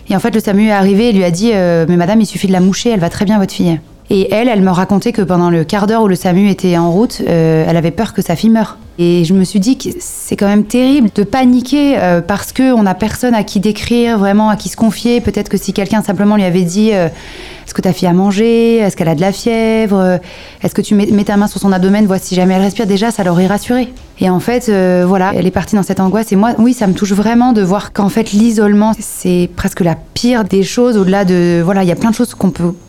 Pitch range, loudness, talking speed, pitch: 185-220 Hz, -11 LUFS, 275 wpm, 200 Hz